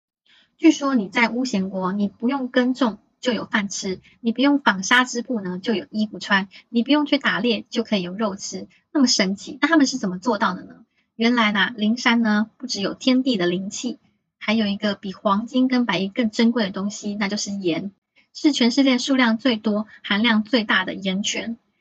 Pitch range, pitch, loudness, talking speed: 200-250 Hz, 225 Hz, -21 LUFS, 285 characters per minute